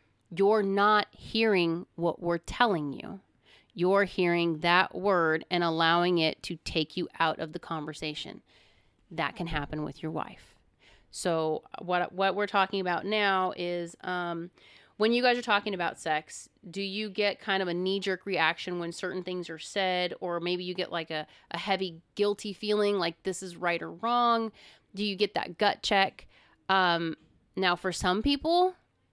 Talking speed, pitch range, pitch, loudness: 175 wpm, 170-200 Hz, 180 Hz, -29 LUFS